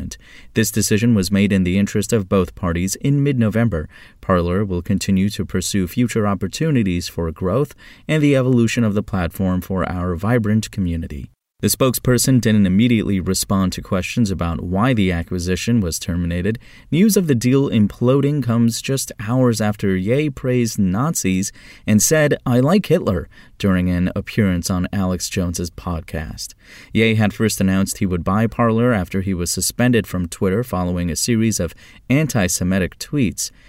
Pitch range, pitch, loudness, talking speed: 90-120 Hz, 100 Hz, -18 LUFS, 160 wpm